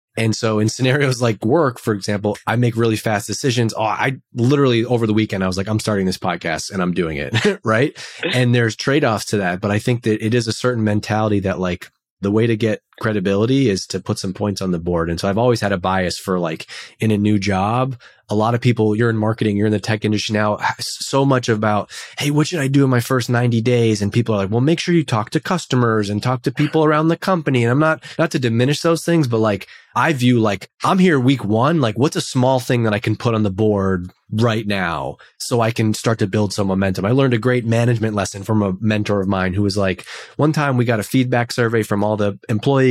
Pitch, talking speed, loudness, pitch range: 110 Hz, 255 wpm, -18 LUFS, 105-125 Hz